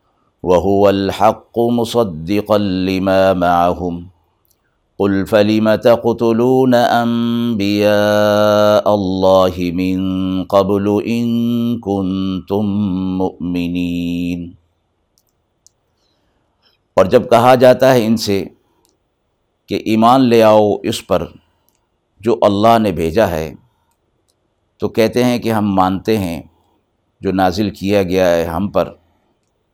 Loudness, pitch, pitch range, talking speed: -14 LUFS, 100 Hz, 95-110 Hz, 95 wpm